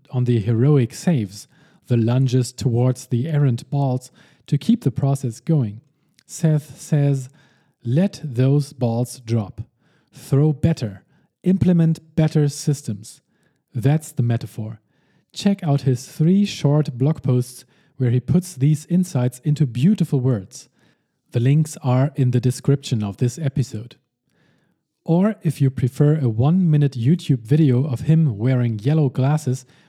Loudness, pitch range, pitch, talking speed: -20 LUFS, 125-155 Hz, 140 Hz, 135 wpm